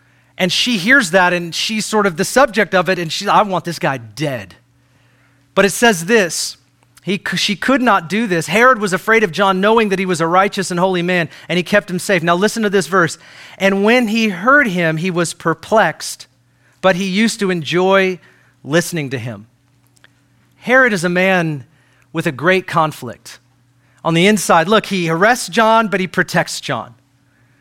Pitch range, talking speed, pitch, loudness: 140-205 Hz, 190 wpm, 180 Hz, -15 LUFS